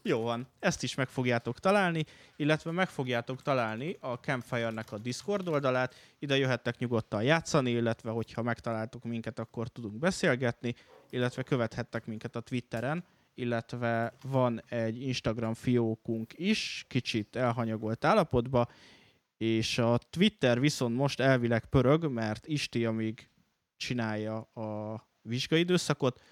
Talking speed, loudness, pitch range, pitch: 125 wpm, -31 LUFS, 115-140 Hz, 120 Hz